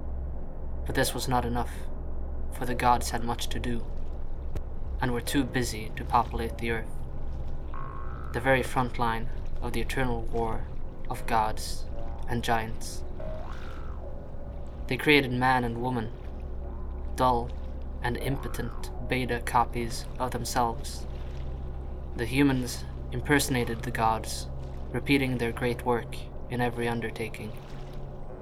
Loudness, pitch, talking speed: -30 LUFS, 75 Hz, 120 wpm